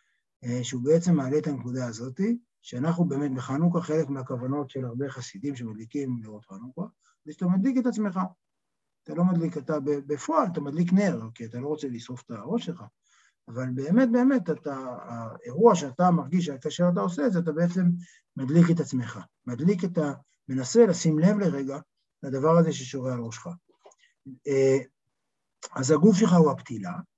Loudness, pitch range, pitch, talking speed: -26 LUFS, 130-175 Hz, 150 Hz, 160 wpm